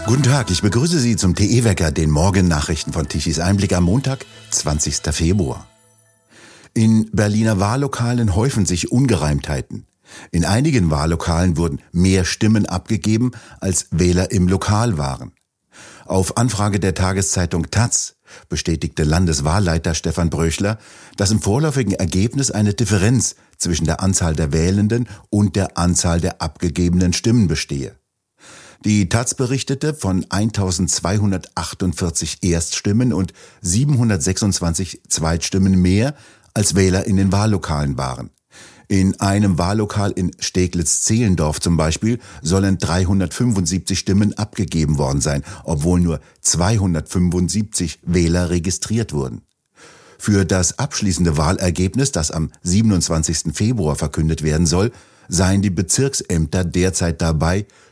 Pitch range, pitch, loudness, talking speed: 85-105 Hz, 95 Hz, -18 LUFS, 115 wpm